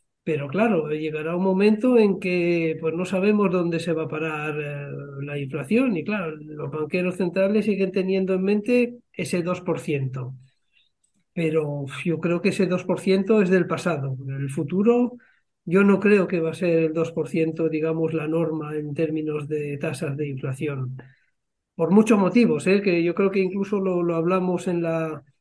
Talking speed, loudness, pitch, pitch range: 170 wpm, -23 LUFS, 170 Hz, 155-190 Hz